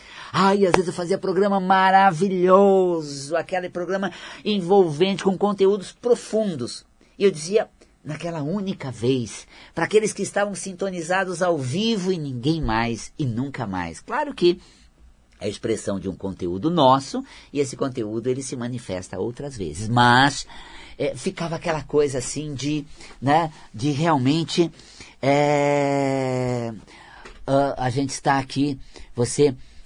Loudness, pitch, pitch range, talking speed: -22 LUFS, 150 Hz, 130-190 Hz, 130 wpm